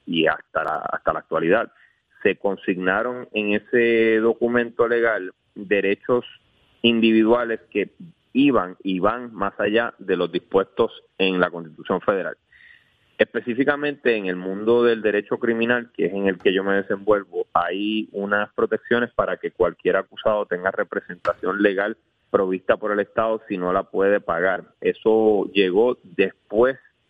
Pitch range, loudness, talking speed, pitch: 100-120 Hz, -22 LUFS, 140 wpm, 115 Hz